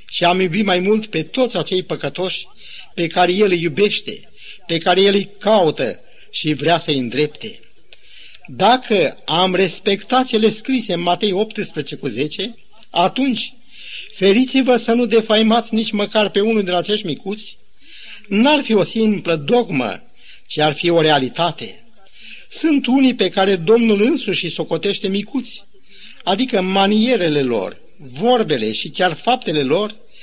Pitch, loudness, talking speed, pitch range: 200 Hz, -17 LUFS, 145 wpm, 175-225 Hz